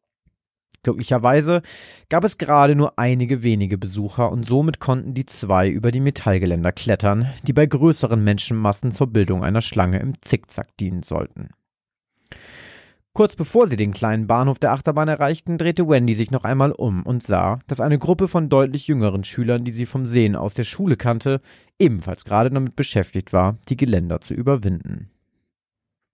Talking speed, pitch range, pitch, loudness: 160 wpm, 105-140 Hz, 120 Hz, -20 LUFS